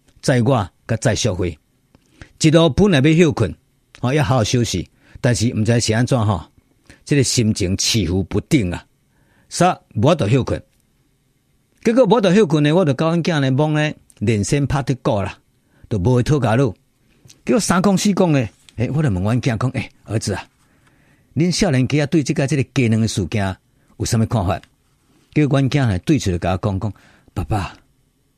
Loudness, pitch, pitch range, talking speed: -18 LUFS, 130 Hz, 110-150 Hz, 245 characters per minute